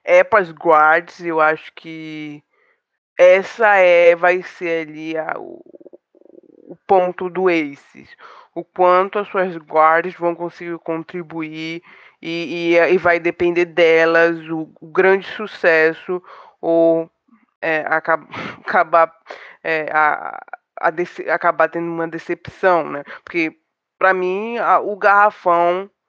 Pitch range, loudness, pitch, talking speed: 165-185 Hz, -17 LUFS, 170 Hz, 125 wpm